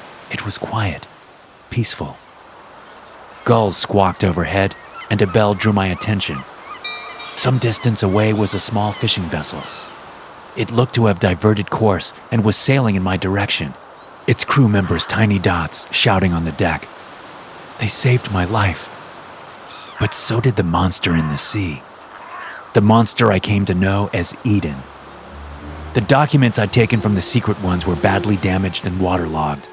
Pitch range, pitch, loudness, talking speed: 90-110 Hz, 100 Hz, -16 LUFS, 150 wpm